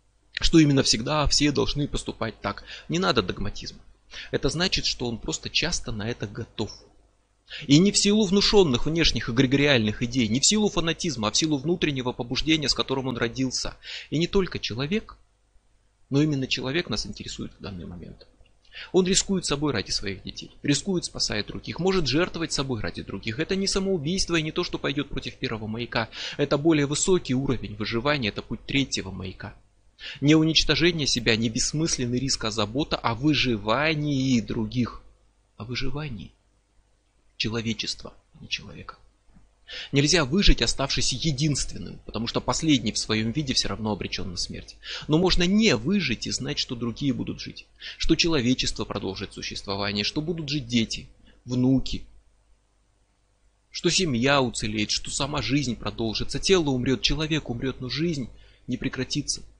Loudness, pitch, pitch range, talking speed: -25 LUFS, 125 Hz, 105-150 Hz, 155 wpm